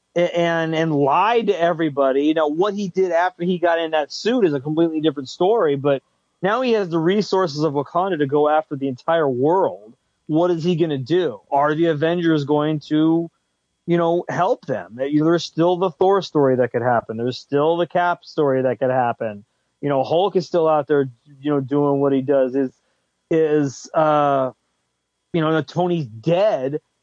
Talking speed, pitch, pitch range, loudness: 195 wpm, 155 Hz, 140-170 Hz, -20 LUFS